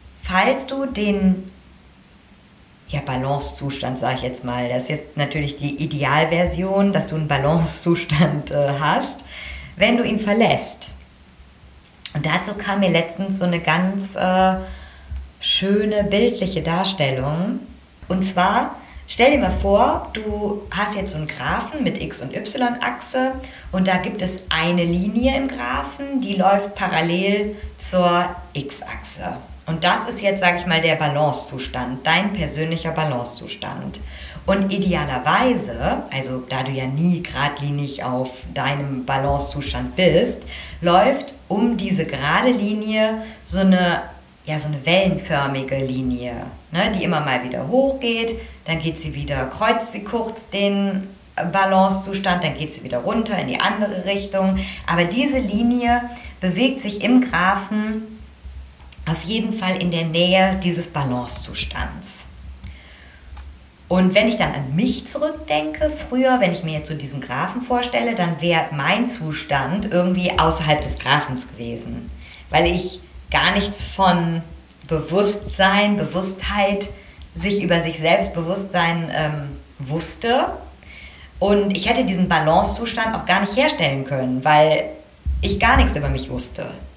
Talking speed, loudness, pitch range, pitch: 135 wpm, -19 LUFS, 145-200 Hz, 175 Hz